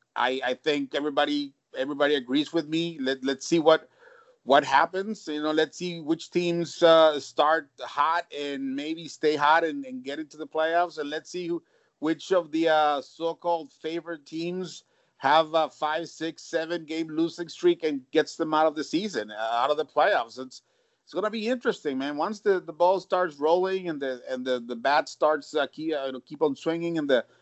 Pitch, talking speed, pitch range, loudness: 160 Hz, 195 wpm, 145-170 Hz, -26 LUFS